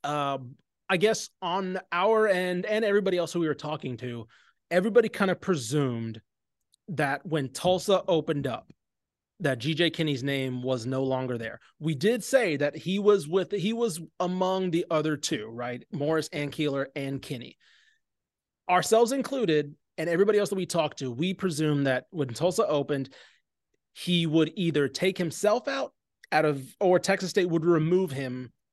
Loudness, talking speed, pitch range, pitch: -27 LUFS, 165 wpm, 145-190 Hz, 165 Hz